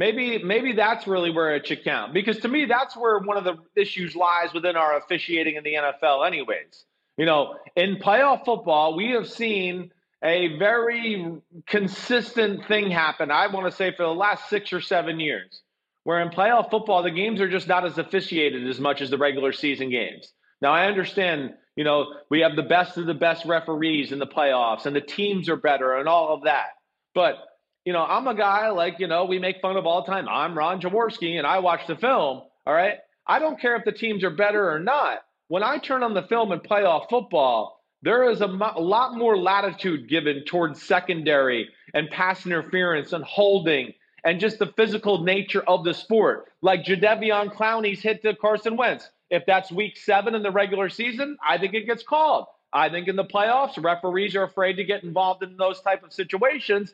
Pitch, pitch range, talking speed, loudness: 185 Hz, 165-210 Hz, 210 wpm, -23 LUFS